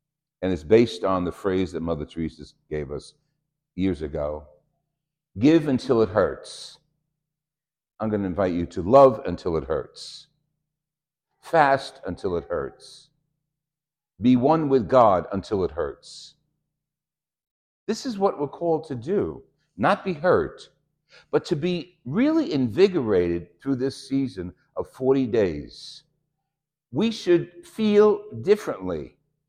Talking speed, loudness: 125 wpm, -23 LUFS